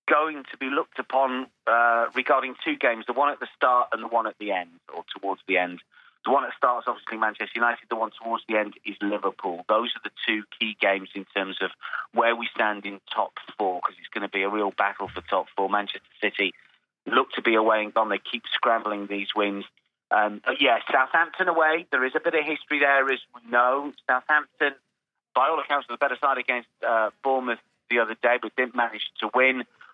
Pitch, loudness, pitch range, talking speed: 115 Hz, -25 LUFS, 105-130 Hz, 220 wpm